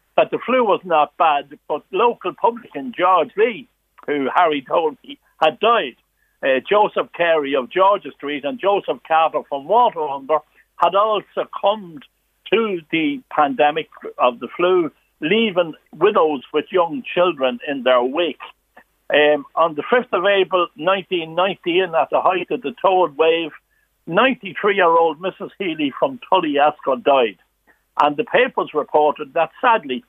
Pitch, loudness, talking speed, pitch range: 175 Hz, -18 LUFS, 140 wpm, 150-205 Hz